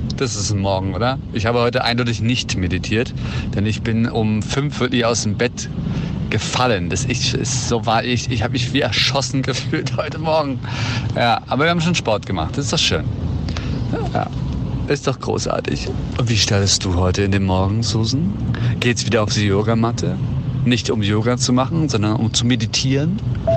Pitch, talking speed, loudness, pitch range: 120 Hz, 185 wpm, -19 LUFS, 110-130 Hz